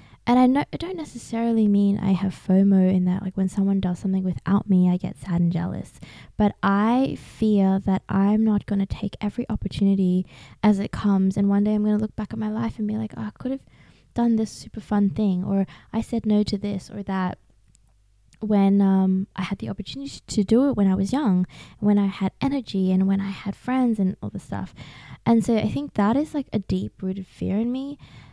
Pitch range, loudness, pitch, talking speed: 190-215 Hz, -23 LUFS, 200 Hz, 230 wpm